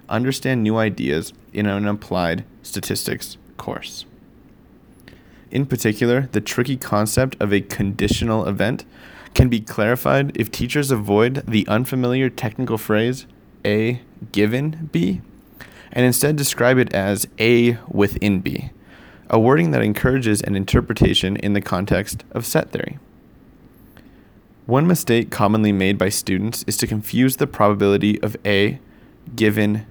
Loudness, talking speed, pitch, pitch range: -19 LUFS, 130 wpm, 110 Hz, 105-125 Hz